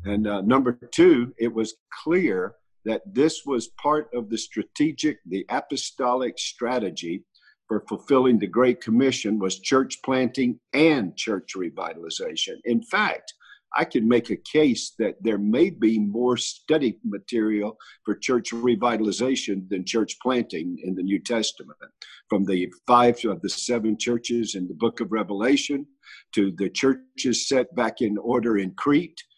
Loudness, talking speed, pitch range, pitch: -24 LUFS, 150 wpm, 105-130 Hz, 120 Hz